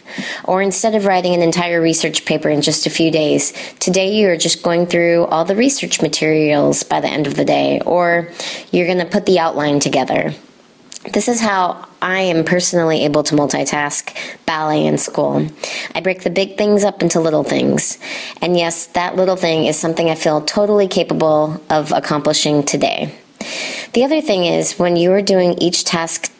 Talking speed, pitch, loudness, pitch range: 185 wpm, 170 Hz, -15 LUFS, 155-185 Hz